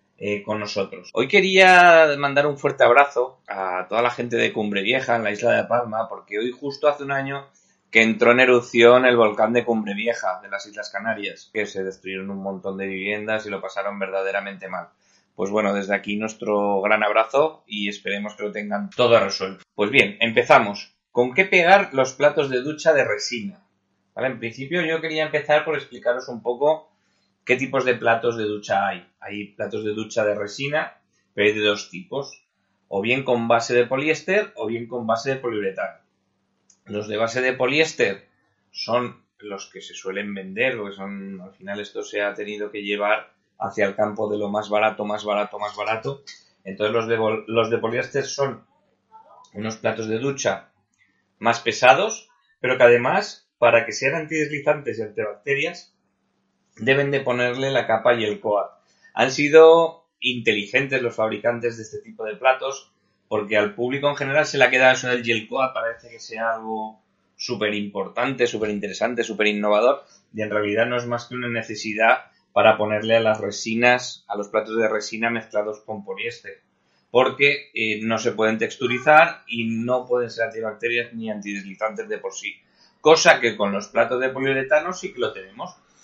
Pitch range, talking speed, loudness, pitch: 105-135 Hz, 185 wpm, -21 LUFS, 115 Hz